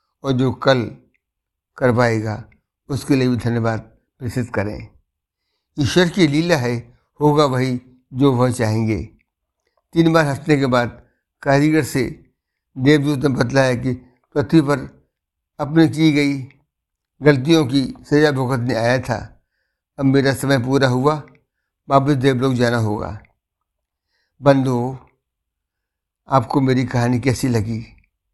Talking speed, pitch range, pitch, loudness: 120 wpm, 115-140 Hz, 130 Hz, -18 LUFS